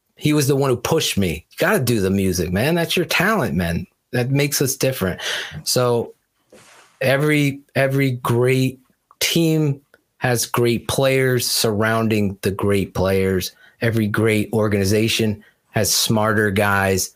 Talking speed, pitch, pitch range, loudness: 135 wpm, 120 Hz, 100-135 Hz, -19 LUFS